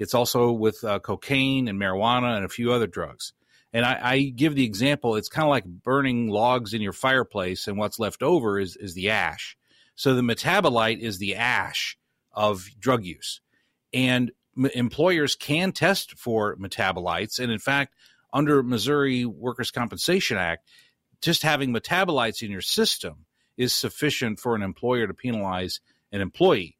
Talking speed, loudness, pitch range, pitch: 165 wpm, -24 LUFS, 105-135 Hz, 120 Hz